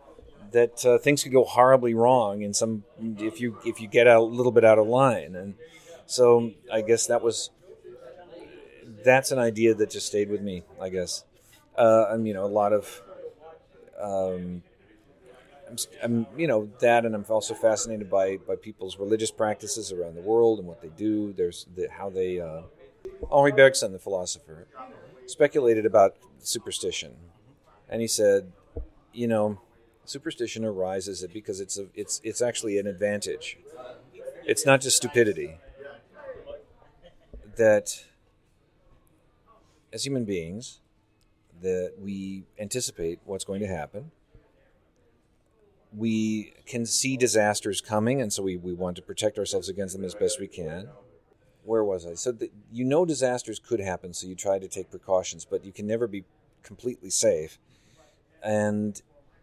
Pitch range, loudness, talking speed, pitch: 100-130 Hz, -25 LUFS, 150 wpm, 110 Hz